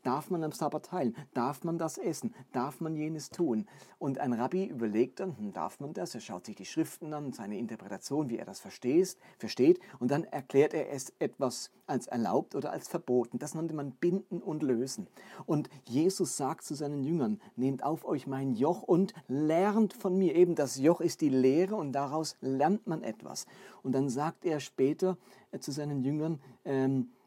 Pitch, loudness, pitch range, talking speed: 155 Hz, -32 LUFS, 135-180 Hz, 190 wpm